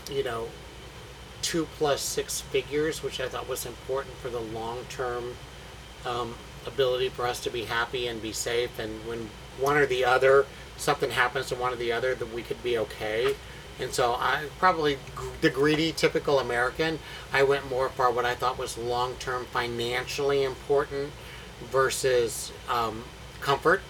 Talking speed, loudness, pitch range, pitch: 160 wpm, -28 LUFS, 120-140 Hz, 130 Hz